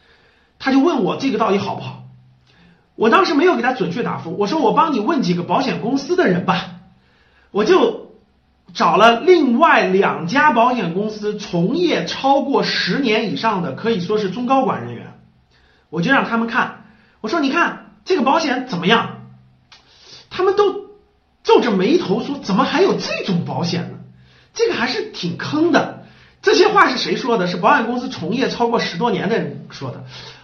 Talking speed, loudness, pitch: 260 characters per minute, -17 LUFS, 230 Hz